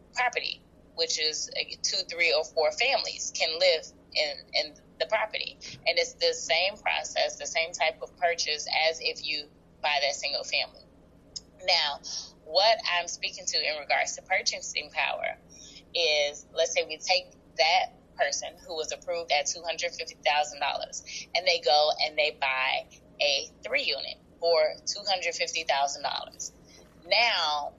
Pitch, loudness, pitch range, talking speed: 170 Hz, -27 LUFS, 155-205 Hz, 140 wpm